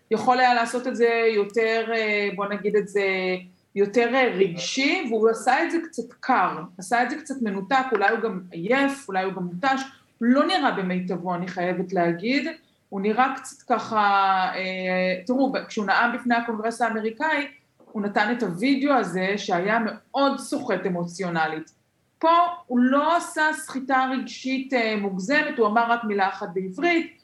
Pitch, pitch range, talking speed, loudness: 230 Hz, 195-265 Hz, 150 wpm, -23 LUFS